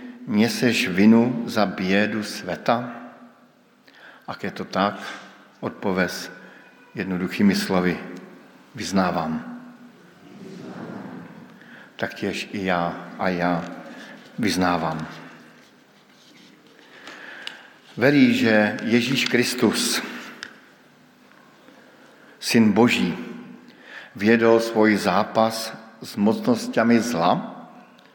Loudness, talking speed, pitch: -21 LUFS, 65 wpm, 115 Hz